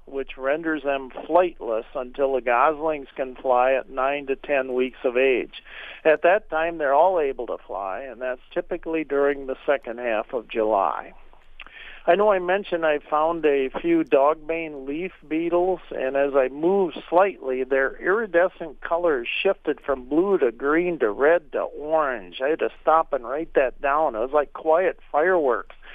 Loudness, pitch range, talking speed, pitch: -23 LUFS, 135-175 Hz, 170 wpm, 155 Hz